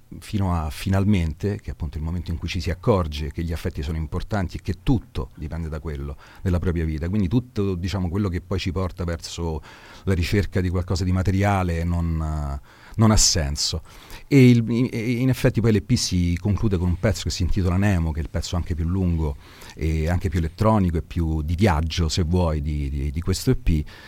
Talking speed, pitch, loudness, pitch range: 210 wpm, 90 Hz, -23 LUFS, 80-100 Hz